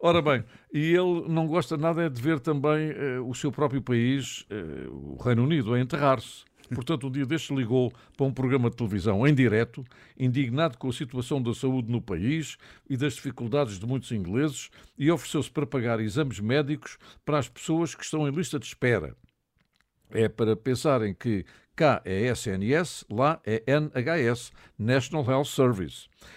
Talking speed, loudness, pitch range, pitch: 170 wpm, -27 LUFS, 120-150 Hz, 135 Hz